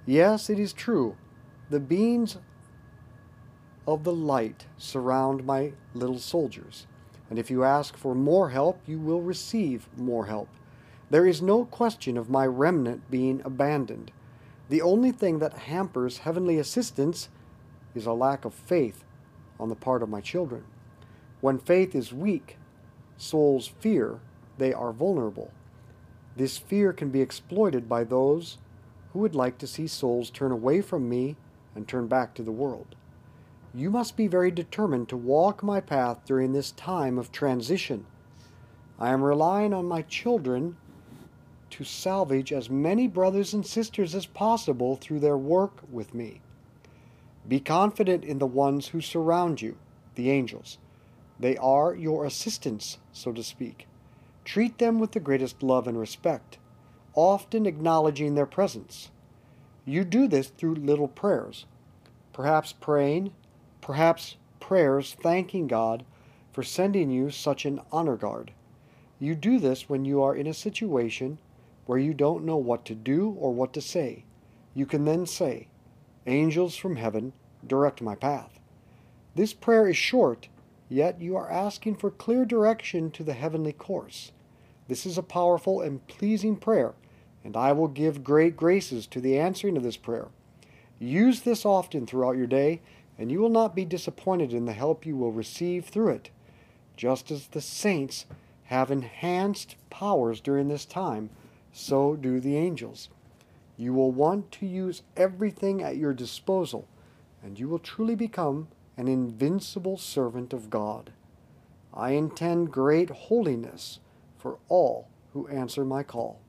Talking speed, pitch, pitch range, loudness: 150 wpm, 140 Hz, 125-175 Hz, -27 LUFS